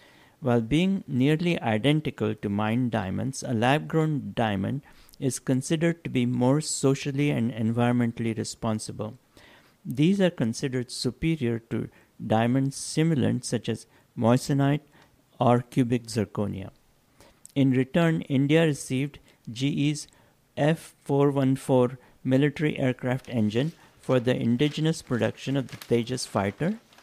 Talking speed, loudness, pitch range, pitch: 110 wpm, -26 LUFS, 120-145 Hz, 130 Hz